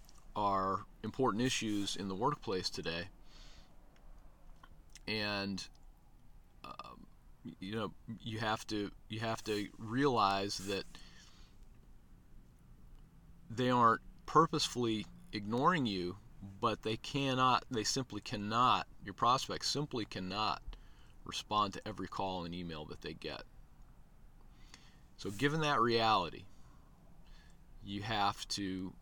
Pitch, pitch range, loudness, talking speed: 105 Hz, 95-115 Hz, -36 LUFS, 105 wpm